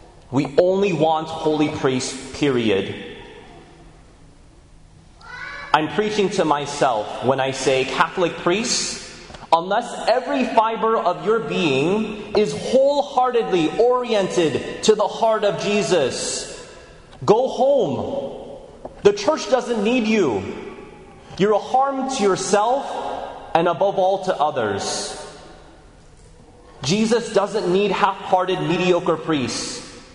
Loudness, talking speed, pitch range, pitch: -20 LUFS, 105 wpm, 160-230 Hz, 200 Hz